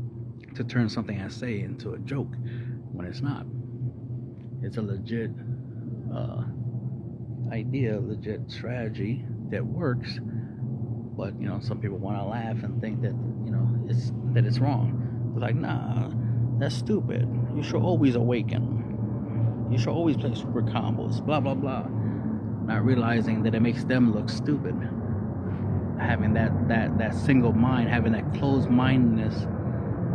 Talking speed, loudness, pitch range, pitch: 145 wpm, -27 LUFS, 115-125 Hz, 120 Hz